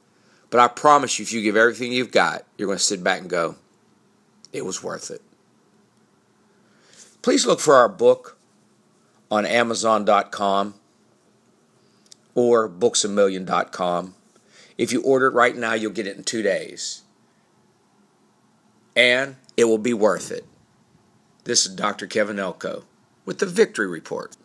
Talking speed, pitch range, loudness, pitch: 140 wpm, 110-150 Hz, -20 LUFS, 120 Hz